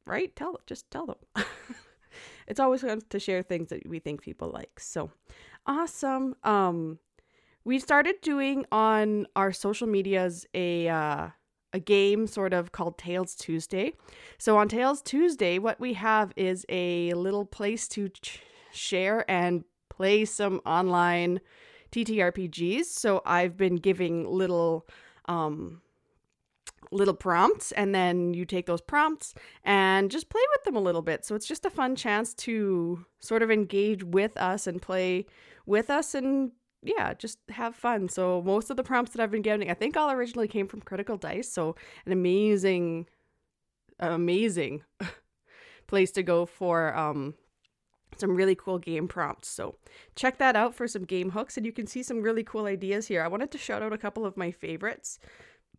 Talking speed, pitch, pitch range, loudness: 170 wpm, 200 Hz, 180-240 Hz, -28 LUFS